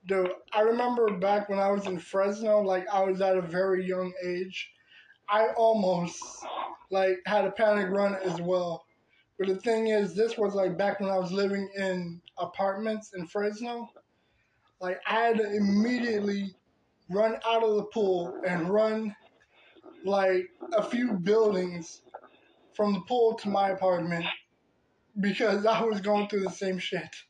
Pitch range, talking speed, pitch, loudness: 185-215 Hz, 160 wpm, 200 Hz, -28 LUFS